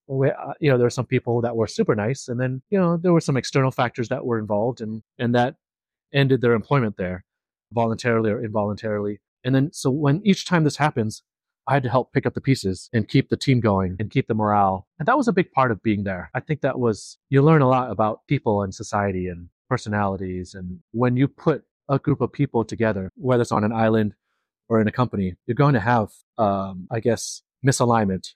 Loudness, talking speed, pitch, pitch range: -22 LUFS, 225 wpm, 120 Hz, 105-135 Hz